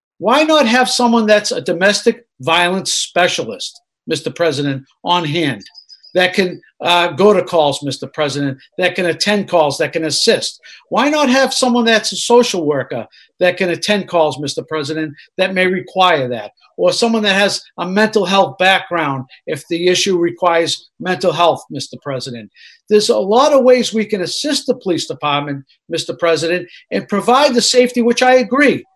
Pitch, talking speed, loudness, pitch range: 185 Hz, 170 wpm, -14 LUFS, 160-235 Hz